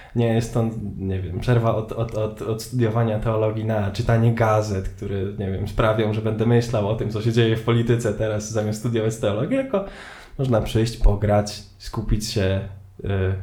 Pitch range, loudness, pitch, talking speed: 105-115 Hz, -23 LUFS, 110 Hz, 185 wpm